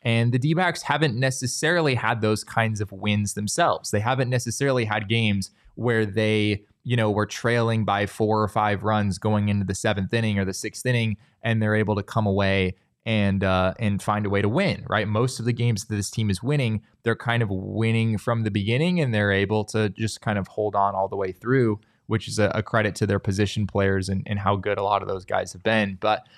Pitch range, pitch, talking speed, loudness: 100-115 Hz, 110 Hz, 230 wpm, -24 LUFS